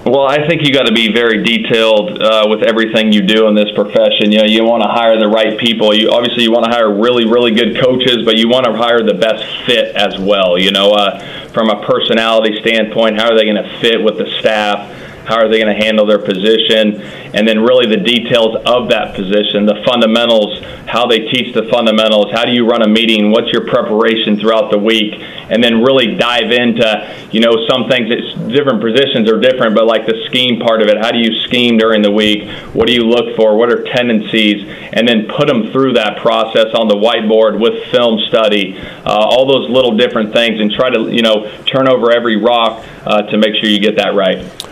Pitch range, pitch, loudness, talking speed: 110-120 Hz, 110 Hz, -11 LUFS, 225 wpm